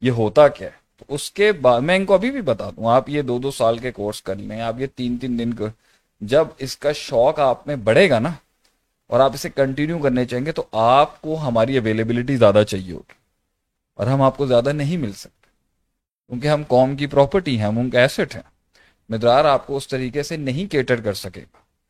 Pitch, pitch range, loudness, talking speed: 130 Hz, 115-145 Hz, -19 LUFS, 225 wpm